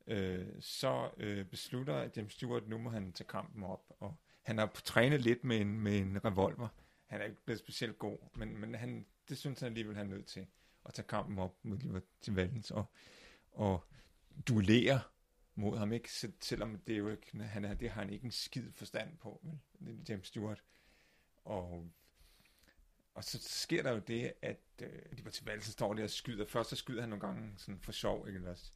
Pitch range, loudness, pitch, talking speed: 100-115 Hz, -40 LUFS, 105 Hz, 205 wpm